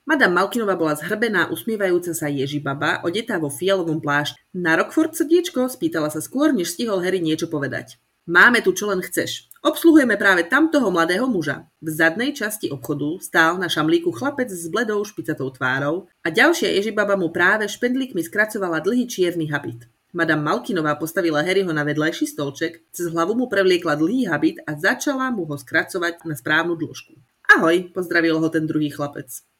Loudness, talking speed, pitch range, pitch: -20 LUFS, 165 wpm, 155-215 Hz, 175 Hz